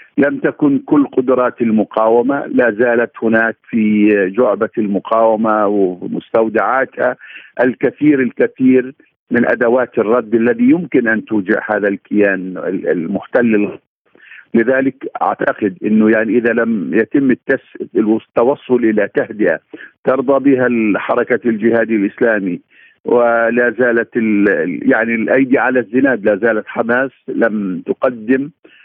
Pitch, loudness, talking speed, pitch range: 115 Hz, -14 LUFS, 110 wpm, 110-125 Hz